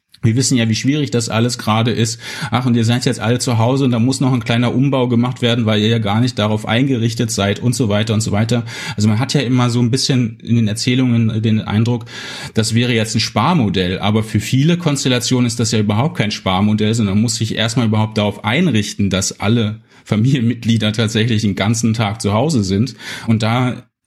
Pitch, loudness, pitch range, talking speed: 115 Hz, -16 LUFS, 110-125 Hz, 220 wpm